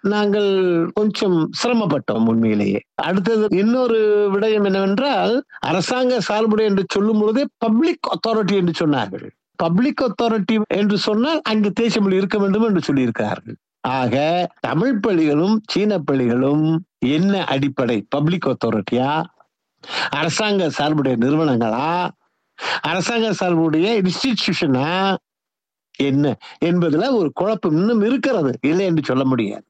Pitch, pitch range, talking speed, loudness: 195 Hz, 150-220 Hz, 105 wpm, -18 LUFS